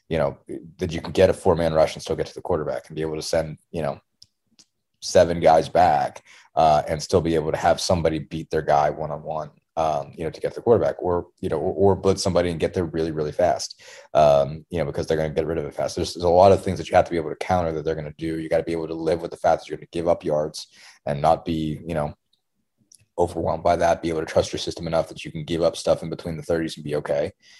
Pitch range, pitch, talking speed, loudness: 80-85 Hz, 80 Hz, 295 wpm, -23 LUFS